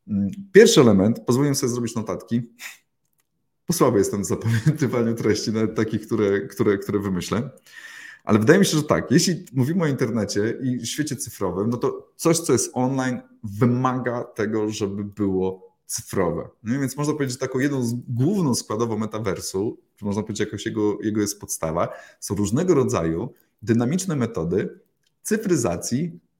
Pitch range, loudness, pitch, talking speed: 105-135 Hz, -22 LUFS, 120 Hz, 155 wpm